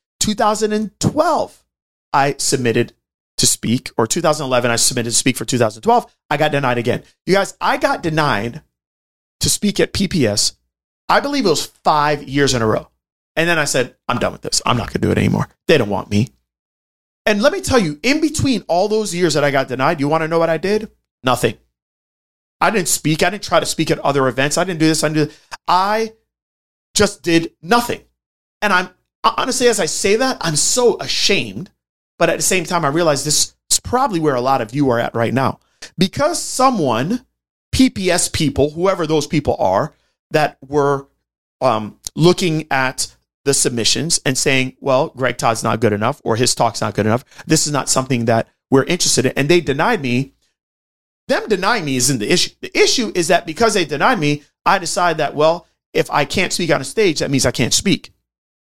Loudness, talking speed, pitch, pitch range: -17 LUFS, 205 wpm, 150 Hz, 125-180 Hz